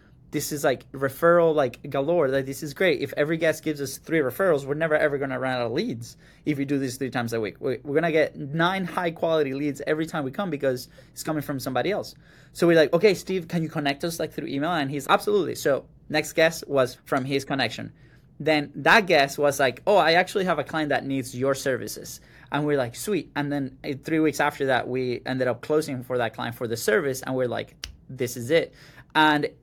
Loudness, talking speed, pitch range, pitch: -24 LUFS, 230 wpm, 135-160 Hz, 145 Hz